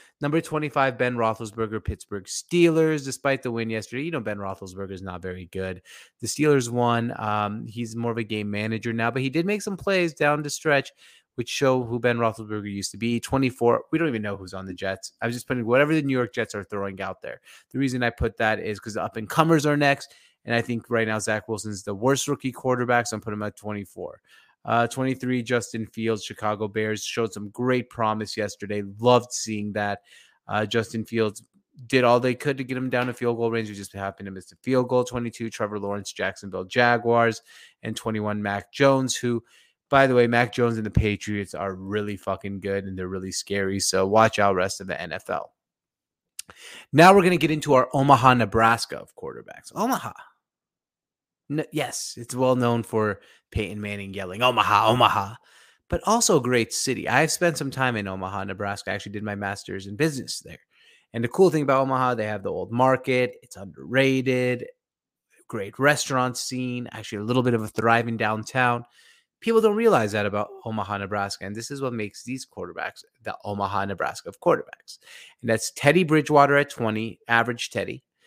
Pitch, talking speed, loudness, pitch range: 115 Hz, 200 wpm, -24 LUFS, 105-130 Hz